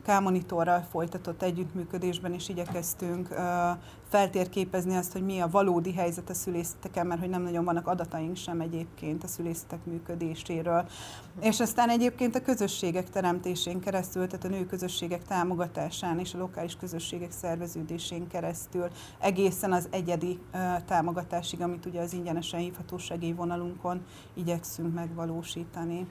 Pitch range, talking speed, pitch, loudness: 170-185 Hz, 125 wpm, 175 Hz, -31 LUFS